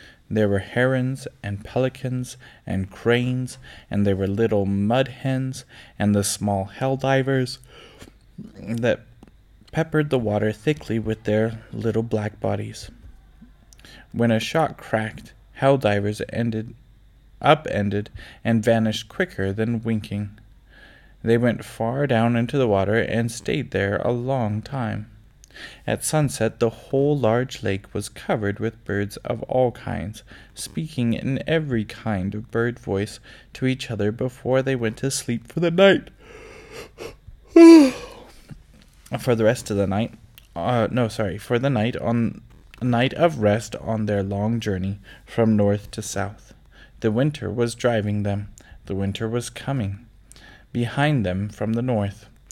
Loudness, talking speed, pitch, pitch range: -22 LUFS, 140 wpm, 115 Hz, 105-130 Hz